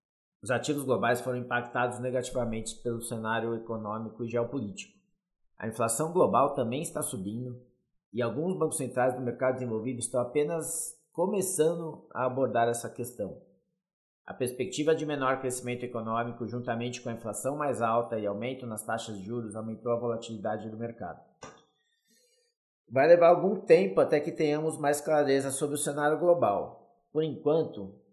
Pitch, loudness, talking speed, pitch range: 125 Hz, -30 LUFS, 145 wpm, 115-155 Hz